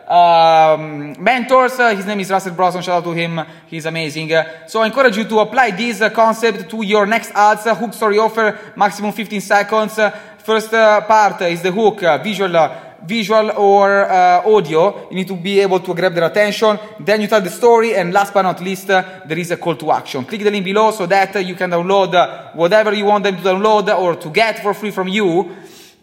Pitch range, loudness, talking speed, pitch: 180-215 Hz, -15 LUFS, 230 wpm, 205 Hz